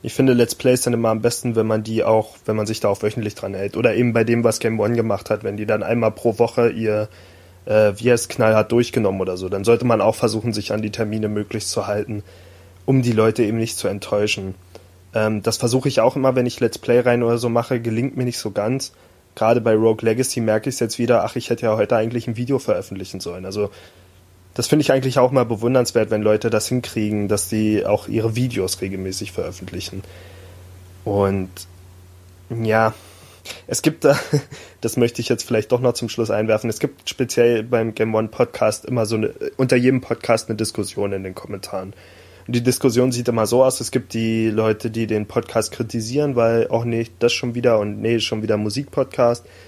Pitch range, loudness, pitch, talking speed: 105-120 Hz, -20 LUFS, 110 Hz, 215 wpm